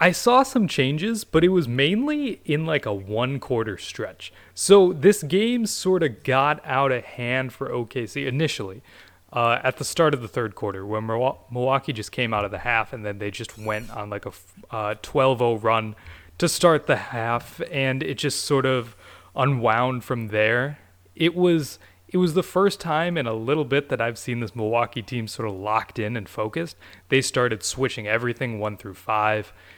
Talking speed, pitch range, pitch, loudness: 190 wpm, 110-150 Hz, 125 Hz, -23 LUFS